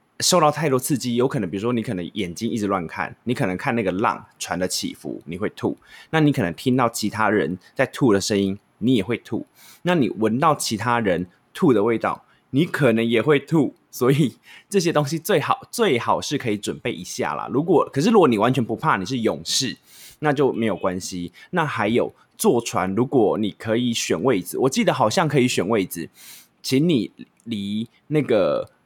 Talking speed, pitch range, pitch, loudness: 285 characters per minute, 100-145 Hz, 115 Hz, -22 LUFS